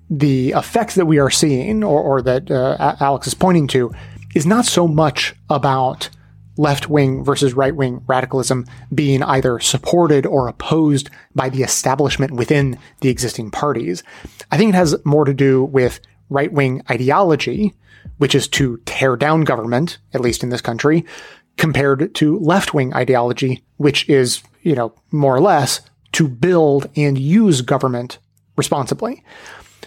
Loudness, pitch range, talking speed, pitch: -16 LUFS, 130-155 Hz, 145 wpm, 140 Hz